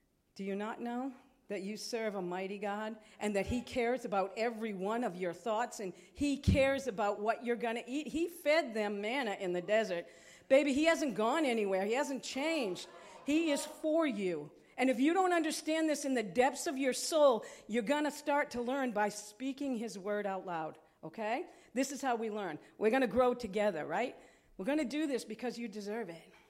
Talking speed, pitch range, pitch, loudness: 210 wpm, 205-275 Hz, 235 Hz, -35 LUFS